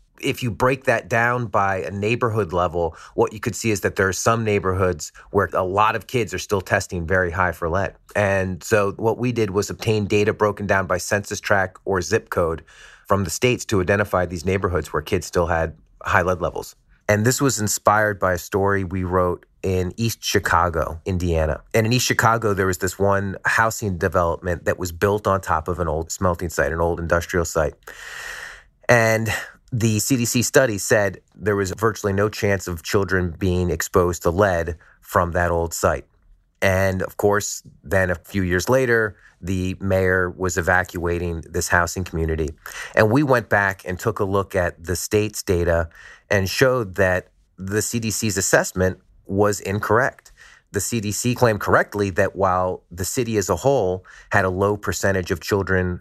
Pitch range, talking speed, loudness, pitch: 90-105 Hz, 180 wpm, -21 LUFS, 95 Hz